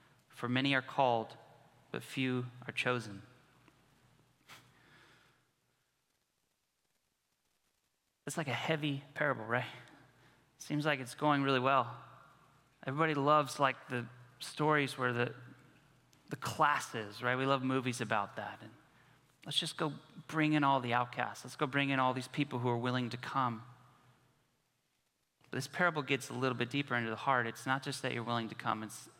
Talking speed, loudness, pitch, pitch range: 155 wpm, -35 LUFS, 130 Hz, 120-140 Hz